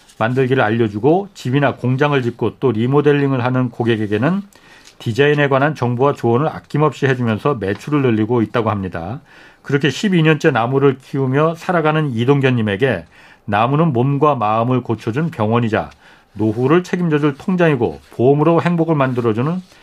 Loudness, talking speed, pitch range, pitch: -16 LUFS, 365 characters per minute, 115-150 Hz, 135 Hz